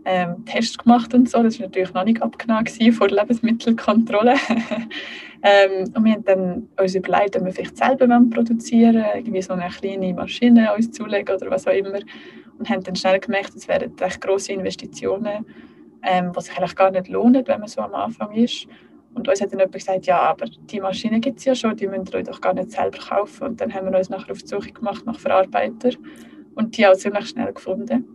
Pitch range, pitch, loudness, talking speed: 190-240 Hz, 210 Hz, -20 LUFS, 215 wpm